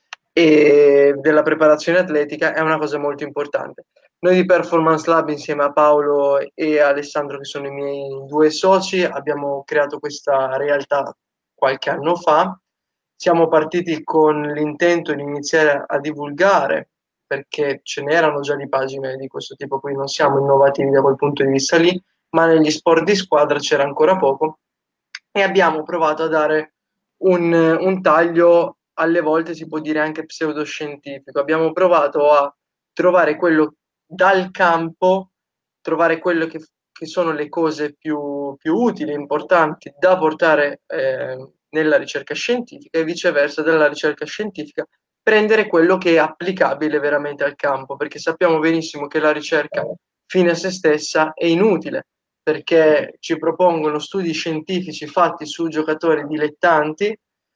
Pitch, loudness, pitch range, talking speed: 155 Hz, -17 LUFS, 145-170 Hz, 145 wpm